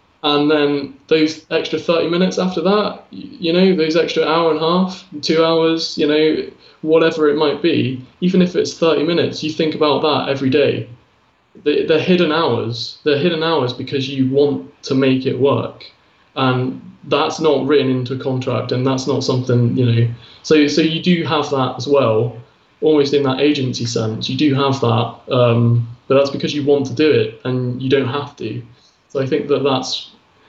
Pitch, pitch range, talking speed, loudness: 145 Hz, 130-160 Hz, 190 wpm, -17 LUFS